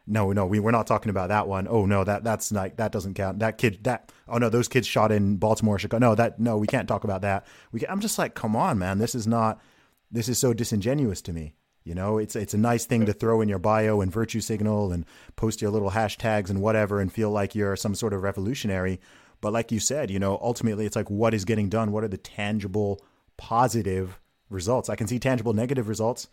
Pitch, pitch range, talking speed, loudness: 110 Hz, 100-115 Hz, 245 wpm, -26 LUFS